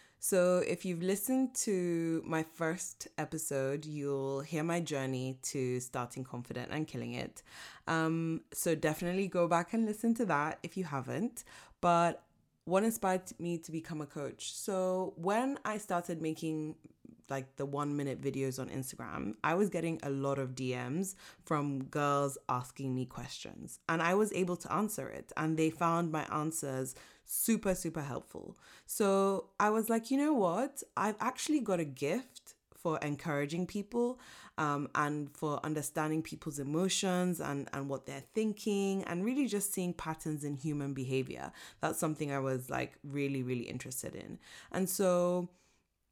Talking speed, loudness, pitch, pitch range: 160 wpm, -35 LUFS, 160 Hz, 140-190 Hz